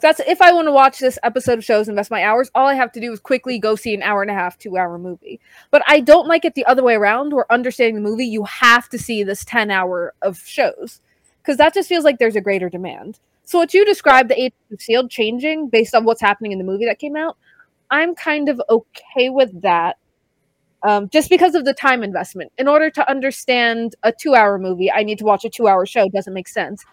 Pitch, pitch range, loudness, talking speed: 235 Hz, 205-280 Hz, -16 LUFS, 245 wpm